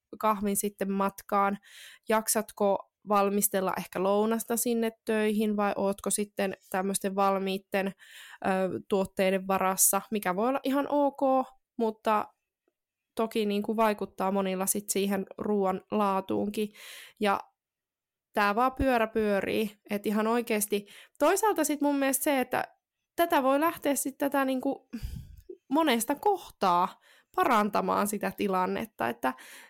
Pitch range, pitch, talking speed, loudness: 195-255 Hz, 215 Hz, 120 wpm, -28 LUFS